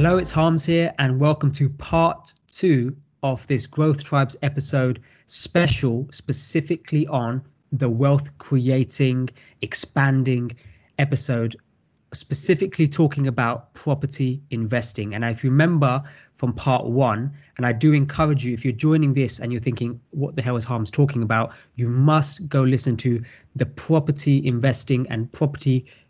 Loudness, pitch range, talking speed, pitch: -21 LUFS, 125-145 Hz, 145 wpm, 135 Hz